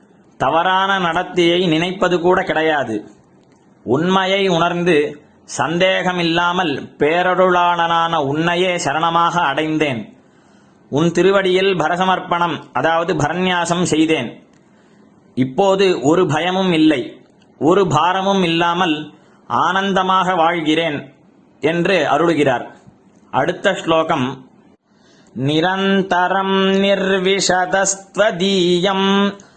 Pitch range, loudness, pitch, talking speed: 165-190 Hz, -16 LUFS, 180 Hz, 65 wpm